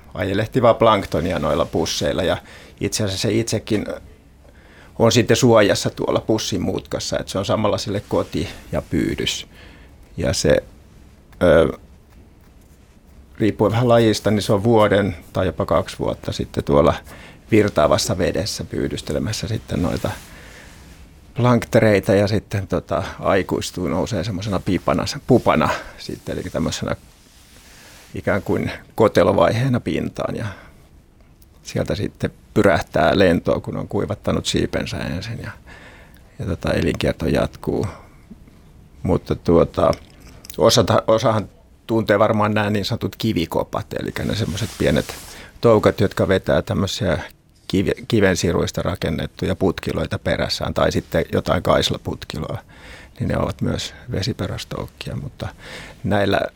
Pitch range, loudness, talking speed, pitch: 80-110 Hz, -20 LUFS, 115 wpm, 95 Hz